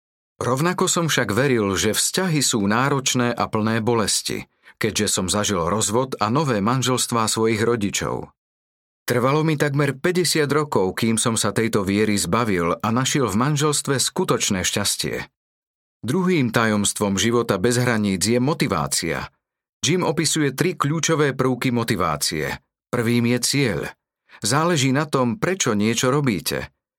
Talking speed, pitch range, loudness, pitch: 130 wpm, 105-145 Hz, -20 LUFS, 120 Hz